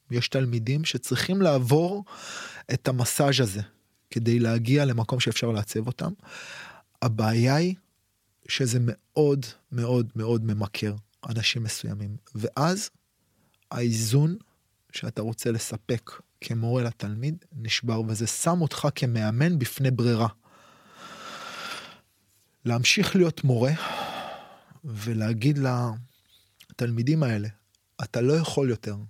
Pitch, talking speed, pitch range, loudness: 120 Hz, 95 wpm, 110-140 Hz, -26 LUFS